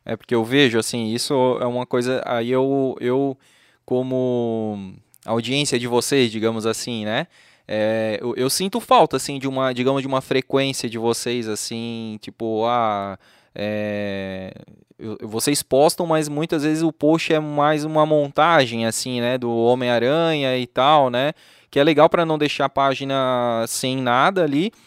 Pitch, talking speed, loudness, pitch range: 125 Hz, 160 wpm, -20 LUFS, 115-140 Hz